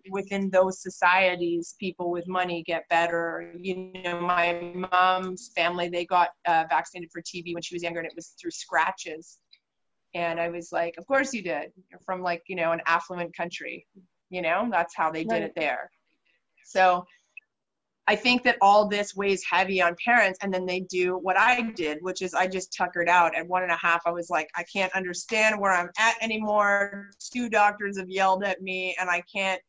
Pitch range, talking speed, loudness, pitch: 170-195 Hz, 200 wpm, -25 LUFS, 185 Hz